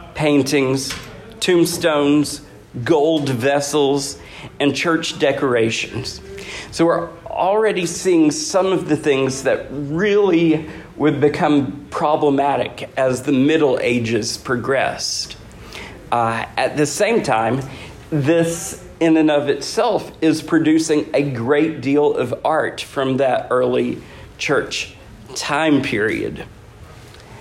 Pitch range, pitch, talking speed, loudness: 130-160 Hz, 145 Hz, 105 wpm, -18 LUFS